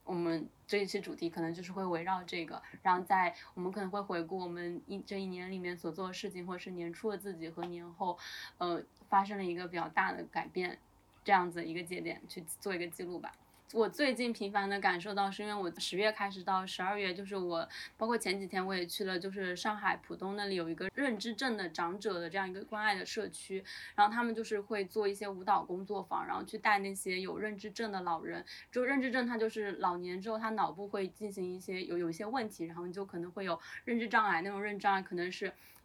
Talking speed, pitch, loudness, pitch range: 350 characters per minute, 190 Hz, -36 LUFS, 180-205 Hz